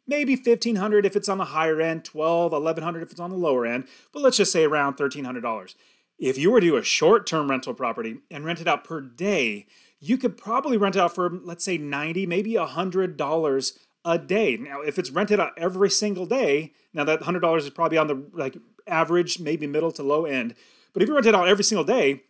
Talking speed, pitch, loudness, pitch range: 220 wpm, 170 Hz, -23 LUFS, 155-205 Hz